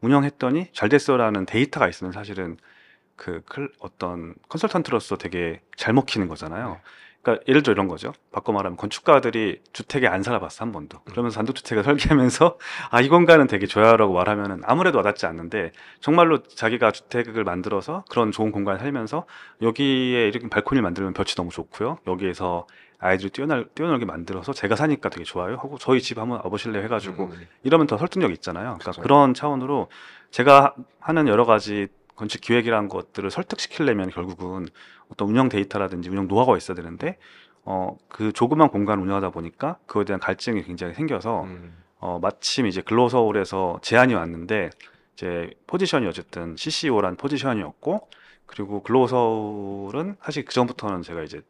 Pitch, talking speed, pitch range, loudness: 105 Hz, 405 characters per minute, 95-130 Hz, -22 LUFS